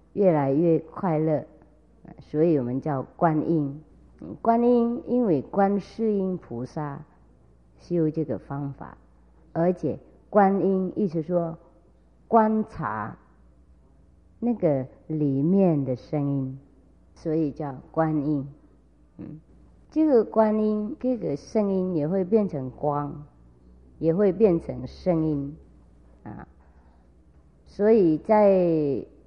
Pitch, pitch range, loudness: 155 Hz, 125-185 Hz, -25 LUFS